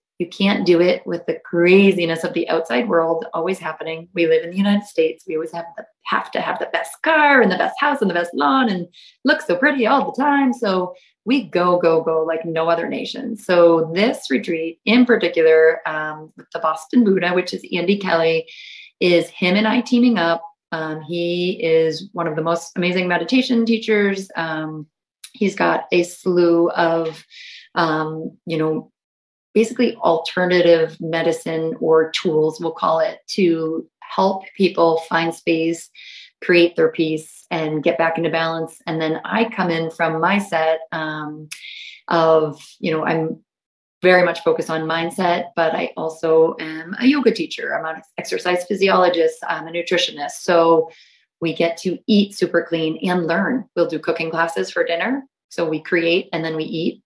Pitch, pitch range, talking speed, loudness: 170 Hz, 160-195 Hz, 175 wpm, -19 LUFS